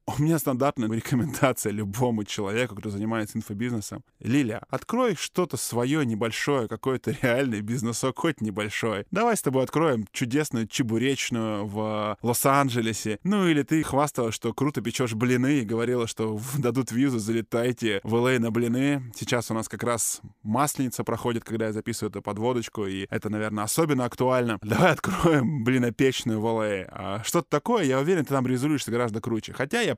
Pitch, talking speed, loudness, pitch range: 120 Hz, 155 wpm, -26 LUFS, 110-135 Hz